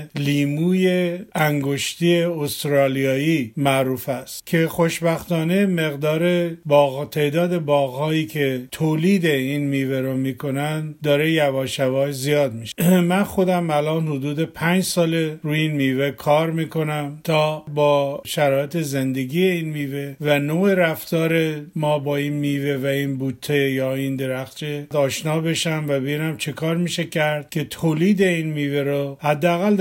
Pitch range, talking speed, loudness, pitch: 140-165 Hz, 130 wpm, -21 LUFS, 150 Hz